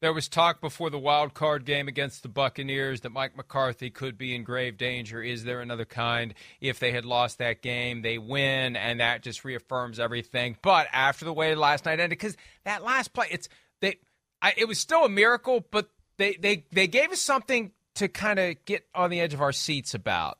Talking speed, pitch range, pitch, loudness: 205 wpm, 125-185 Hz, 140 Hz, -27 LUFS